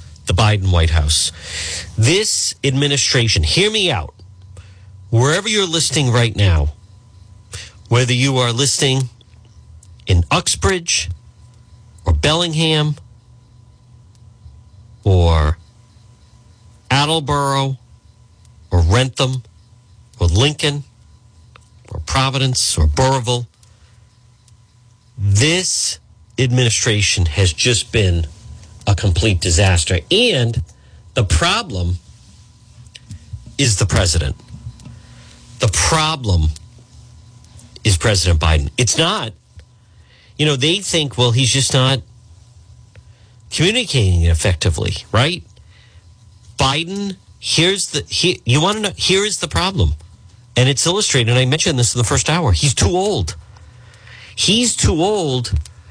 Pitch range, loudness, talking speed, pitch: 95-130 Hz, -16 LUFS, 100 wpm, 110 Hz